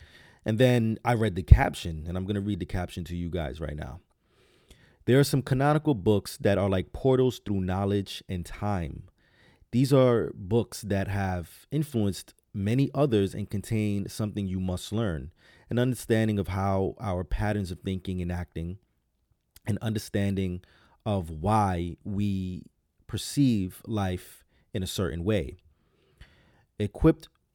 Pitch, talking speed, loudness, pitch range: 100 Hz, 145 wpm, -28 LUFS, 90-110 Hz